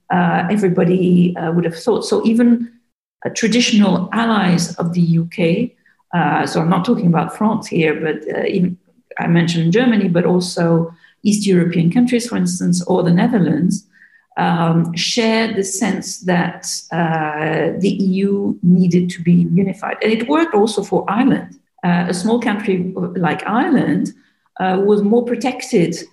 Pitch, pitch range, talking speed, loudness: 185 Hz, 175-220 Hz, 150 wpm, -16 LUFS